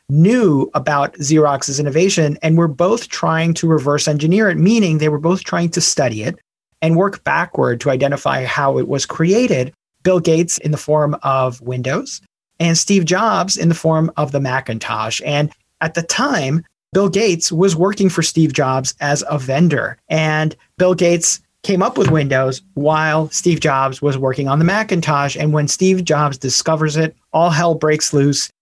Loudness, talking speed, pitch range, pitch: -16 LUFS, 175 wpm, 145-175 Hz, 155 Hz